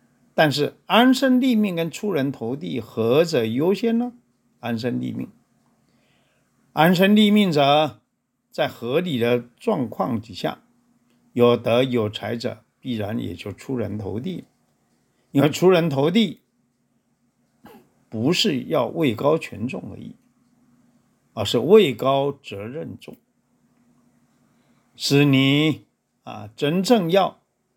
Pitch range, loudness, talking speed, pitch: 120-200 Hz, -21 LUFS, 160 characters per minute, 140 Hz